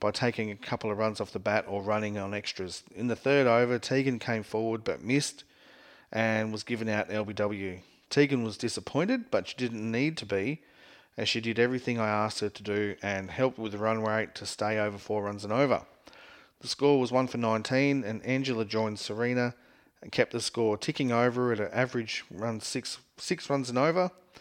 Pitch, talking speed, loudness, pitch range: 115 Hz, 205 wpm, -30 LUFS, 105-130 Hz